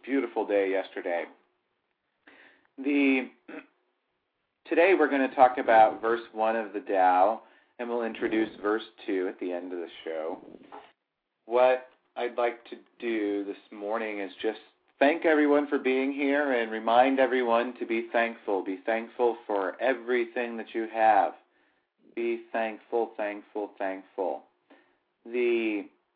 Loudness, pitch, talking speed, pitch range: -27 LUFS, 115 Hz, 135 wpm, 105-125 Hz